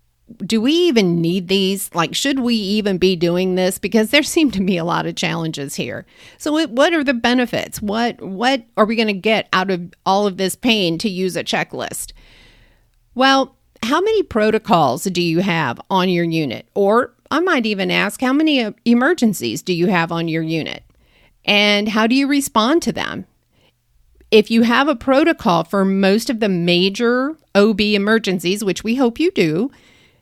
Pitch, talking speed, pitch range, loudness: 205 Hz, 185 wpm, 185-250 Hz, -17 LUFS